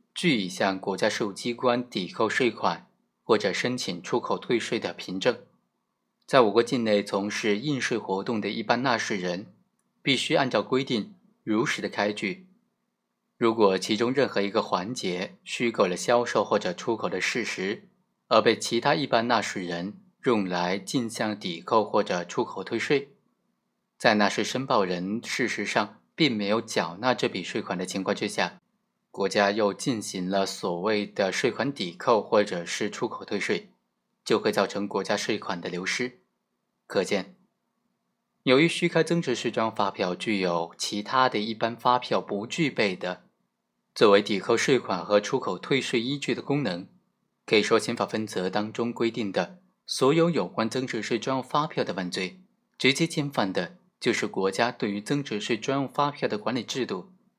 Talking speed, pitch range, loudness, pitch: 250 characters per minute, 105-135 Hz, -26 LUFS, 115 Hz